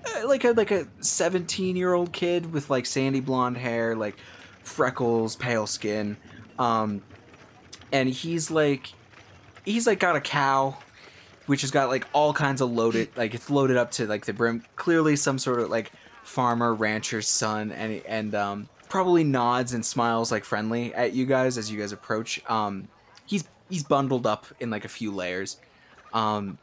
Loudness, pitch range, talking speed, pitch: -25 LUFS, 110-140 Hz, 170 wpm, 120 Hz